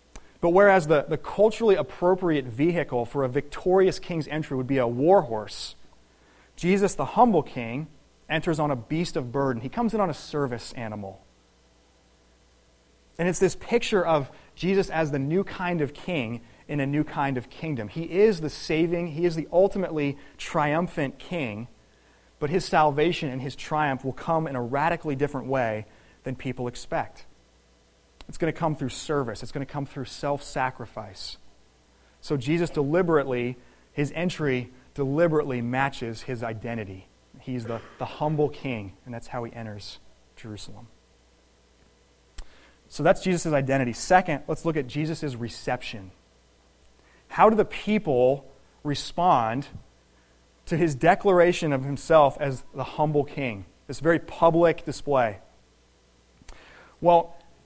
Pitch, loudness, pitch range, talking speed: 140 Hz, -25 LUFS, 110-160 Hz, 145 wpm